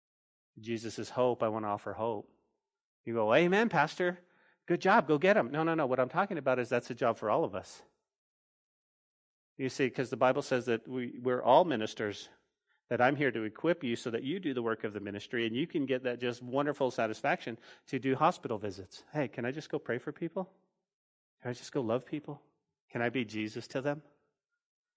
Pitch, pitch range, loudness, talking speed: 130 Hz, 115-155 Hz, -32 LUFS, 220 wpm